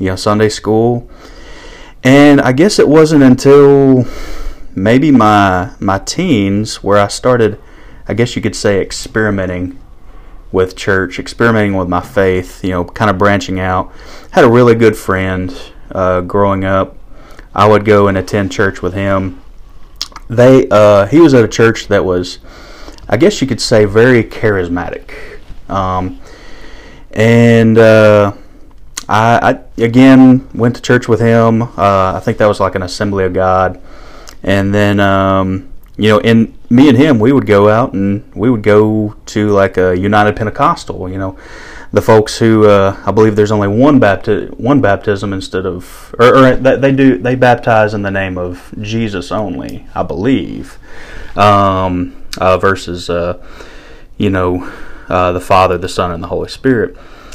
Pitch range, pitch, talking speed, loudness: 95-115 Hz, 105 Hz, 160 wpm, -10 LUFS